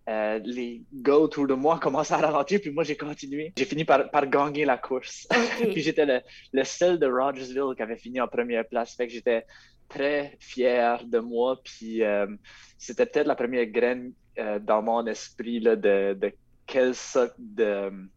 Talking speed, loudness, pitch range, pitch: 190 wpm, -26 LUFS, 115-150 Hz, 130 Hz